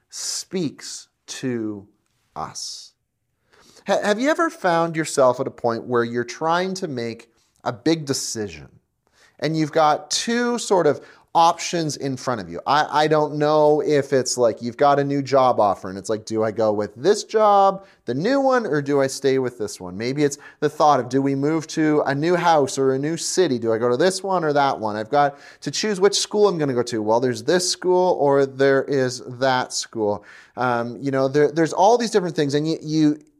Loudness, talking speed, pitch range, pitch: -20 LUFS, 215 wpm, 120-165 Hz, 140 Hz